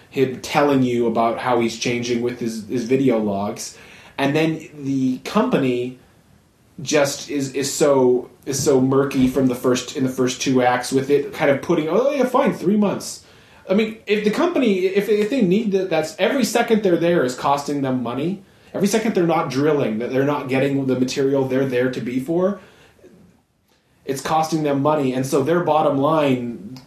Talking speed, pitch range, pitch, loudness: 190 wpm, 130-170 Hz, 140 Hz, -20 LUFS